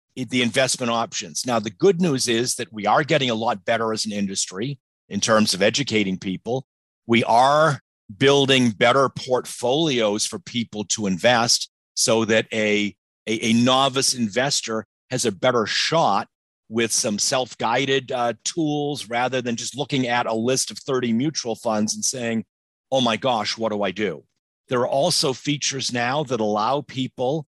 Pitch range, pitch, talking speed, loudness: 110-130 Hz, 120 Hz, 165 wpm, -21 LUFS